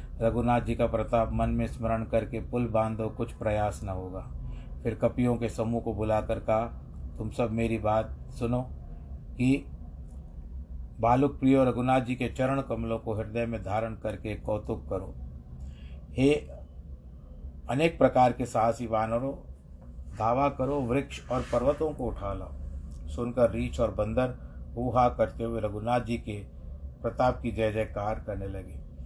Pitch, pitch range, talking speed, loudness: 110 Hz, 75-120 Hz, 150 wpm, -29 LUFS